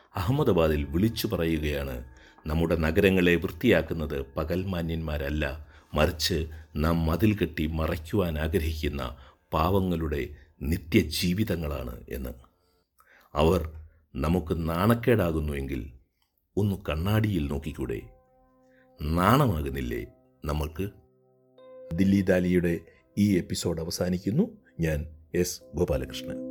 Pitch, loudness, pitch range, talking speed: 85 Hz, -28 LUFS, 75-95 Hz, 70 wpm